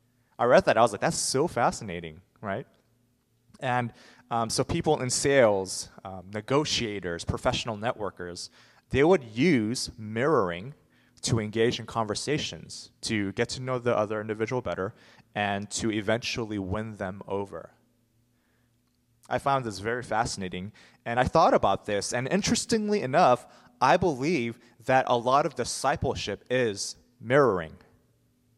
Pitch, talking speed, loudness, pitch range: 115 Hz, 135 wpm, -27 LUFS, 105-125 Hz